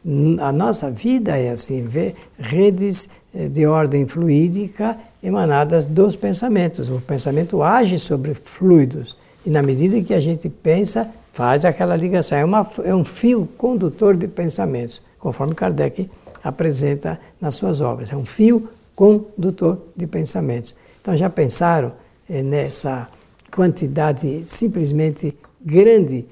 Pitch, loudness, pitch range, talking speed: 165 Hz, -18 LUFS, 145-195 Hz, 125 wpm